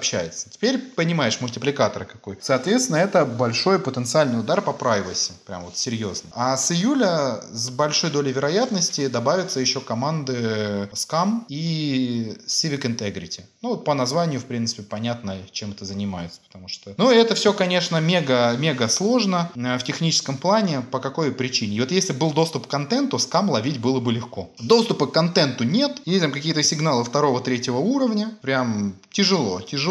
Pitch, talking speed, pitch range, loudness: 140 Hz, 155 wpm, 120-175 Hz, -22 LUFS